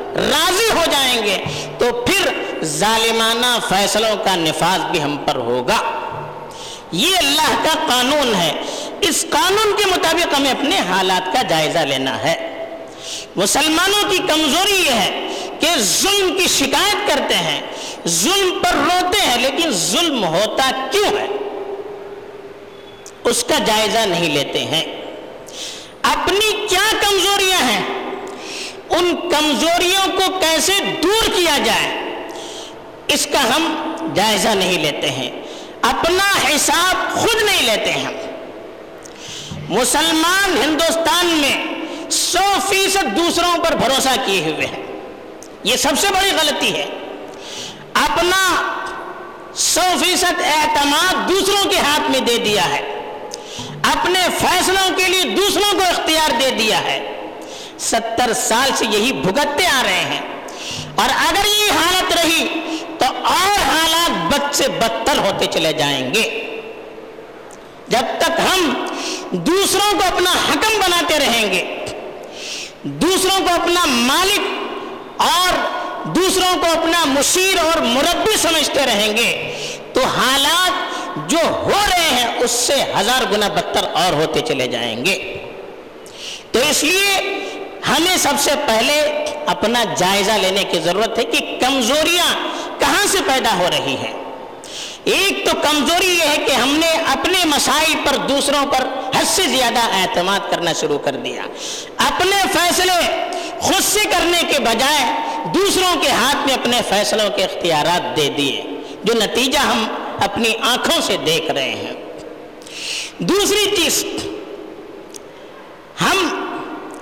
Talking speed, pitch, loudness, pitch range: 130 wpm, 345 Hz, -15 LUFS, 285-380 Hz